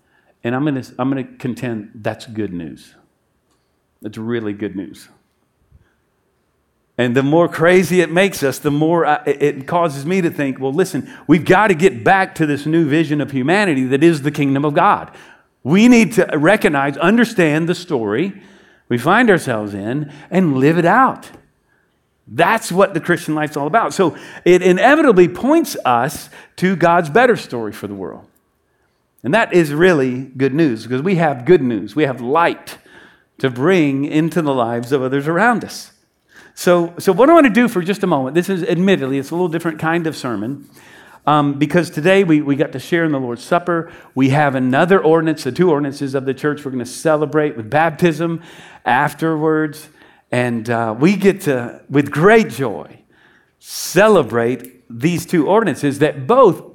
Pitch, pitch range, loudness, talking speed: 155 Hz, 135-175 Hz, -15 LUFS, 180 wpm